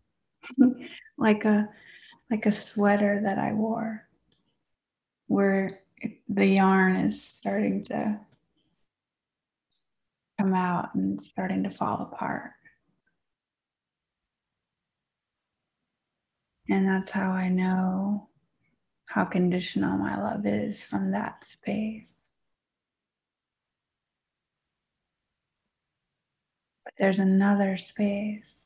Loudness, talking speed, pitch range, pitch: -27 LUFS, 80 wpm, 185-215 Hz, 195 Hz